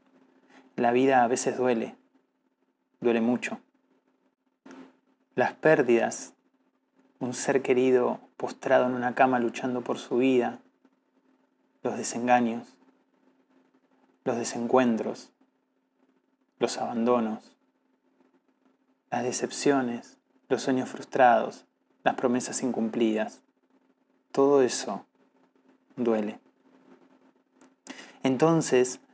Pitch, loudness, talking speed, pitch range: 125 Hz, -26 LUFS, 80 wpm, 120-135 Hz